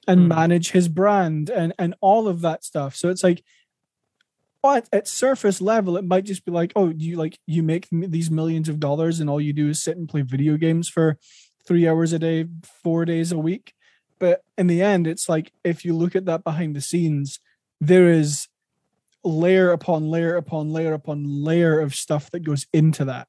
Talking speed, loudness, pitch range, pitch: 205 wpm, -21 LUFS, 160-180 Hz, 165 Hz